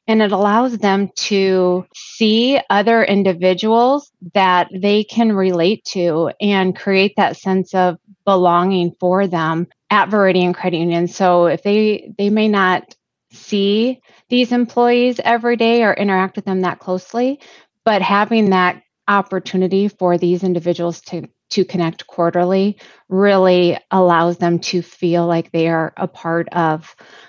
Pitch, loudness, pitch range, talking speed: 190 Hz, -16 LUFS, 175-210 Hz, 140 wpm